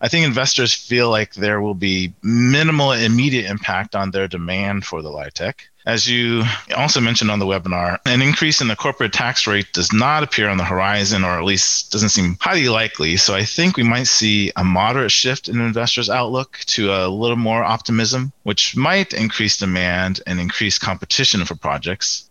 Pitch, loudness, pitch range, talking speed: 110 Hz, -17 LUFS, 95-120 Hz, 190 wpm